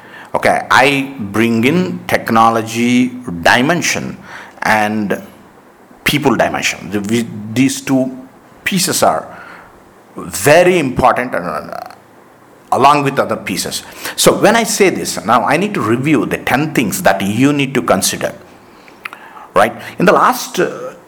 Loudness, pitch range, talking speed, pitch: -13 LUFS, 105-135 Hz, 130 wpm, 120 Hz